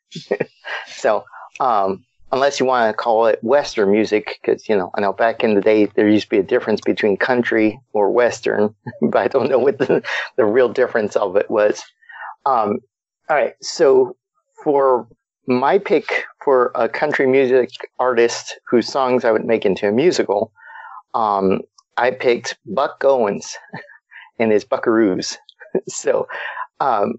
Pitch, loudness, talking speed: 130 Hz, -18 LUFS, 155 wpm